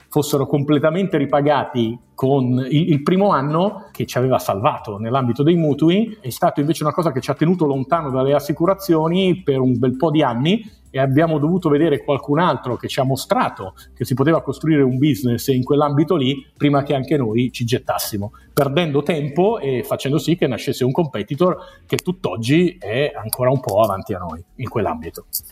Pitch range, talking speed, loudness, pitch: 130-160 Hz, 180 wpm, -19 LUFS, 145 Hz